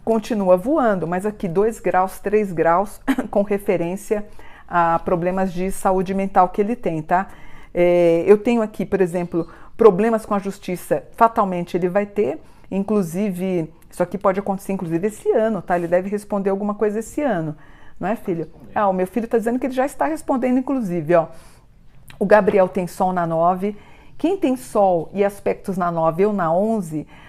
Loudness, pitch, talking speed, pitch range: -20 LUFS, 195 Hz, 180 wpm, 180-215 Hz